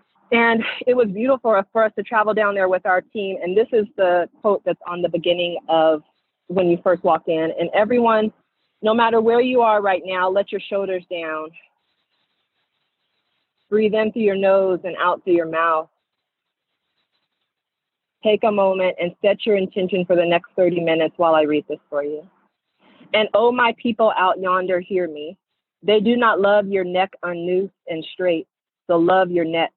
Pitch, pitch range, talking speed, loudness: 190 Hz, 175-215 Hz, 185 wpm, -19 LUFS